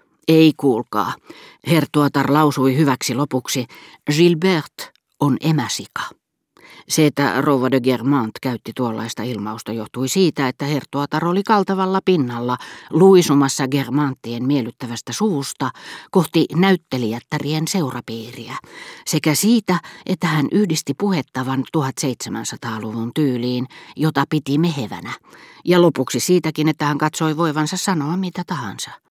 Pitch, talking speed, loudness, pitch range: 145 Hz, 105 wpm, -19 LUFS, 130-165 Hz